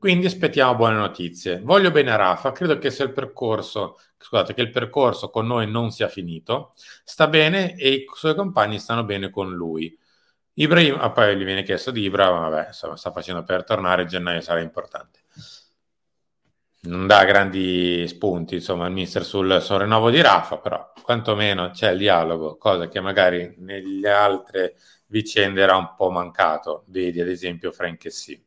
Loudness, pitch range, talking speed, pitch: -20 LUFS, 90-125 Hz, 170 wpm, 100 Hz